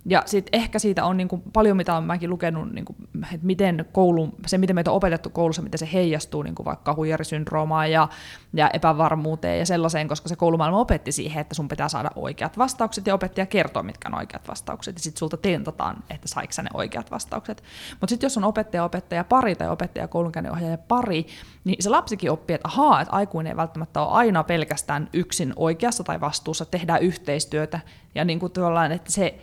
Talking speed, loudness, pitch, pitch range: 195 wpm, -24 LUFS, 170 Hz, 160-190 Hz